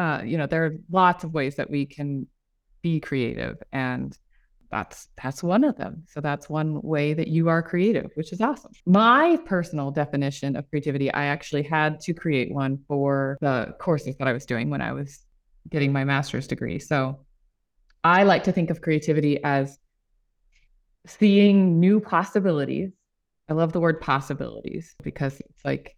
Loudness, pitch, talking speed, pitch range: -24 LUFS, 150 Hz, 170 wpm, 140-175 Hz